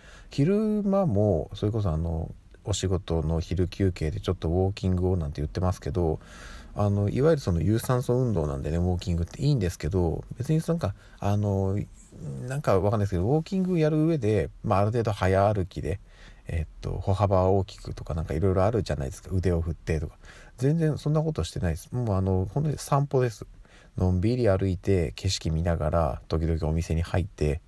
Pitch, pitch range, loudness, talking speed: 95 Hz, 85-120 Hz, -27 LUFS, 410 characters per minute